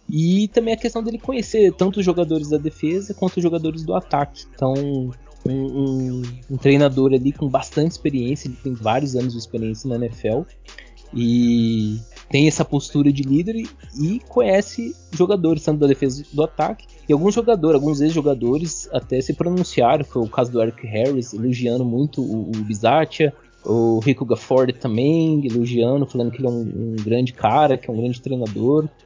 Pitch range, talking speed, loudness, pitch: 120-160 Hz, 180 wpm, -20 LUFS, 140 Hz